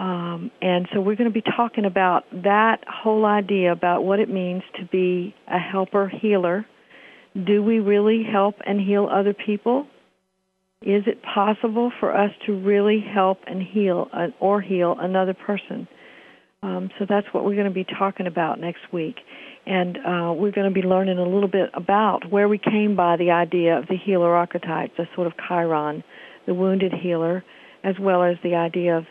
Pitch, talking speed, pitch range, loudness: 190 Hz, 185 wpm, 180-205 Hz, -22 LUFS